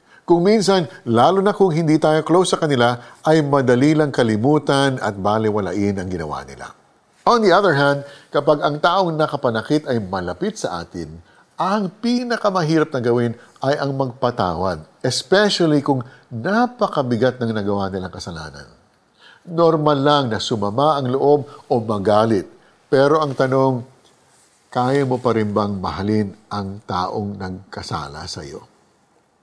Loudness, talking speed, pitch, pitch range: -18 LUFS, 135 wpm, 130 Hz, 105-155 Hz